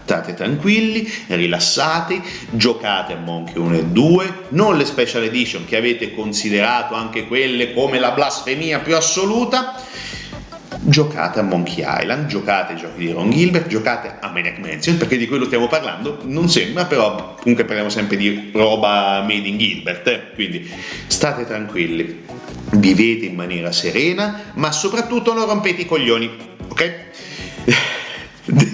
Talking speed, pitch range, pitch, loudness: 140 wpm, 105-165 Hz, 120 Hz, -17 LUFS